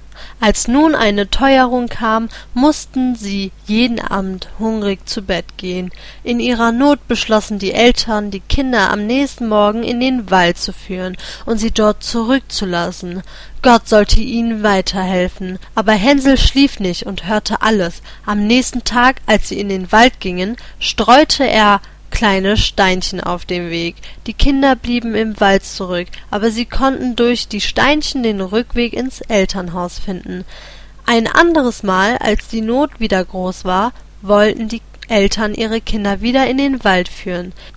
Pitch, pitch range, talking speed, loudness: 220 Hz, 190-240 Hz, 155 wpm, -15 LUFS